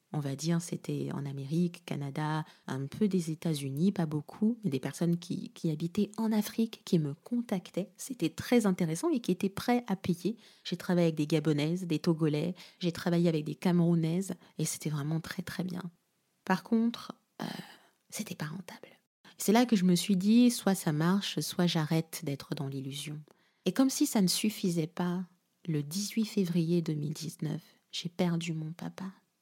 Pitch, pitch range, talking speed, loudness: 175 Hz, 160-195 Hz, 175 wpm, -32 LUFS